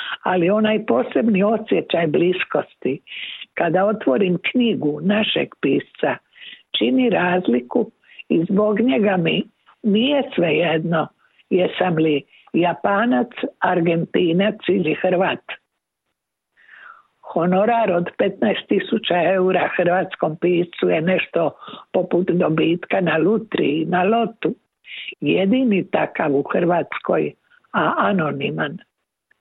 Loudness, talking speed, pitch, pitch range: -19 LUFS, 95 wpm, 190 Hz, 175-225 Hz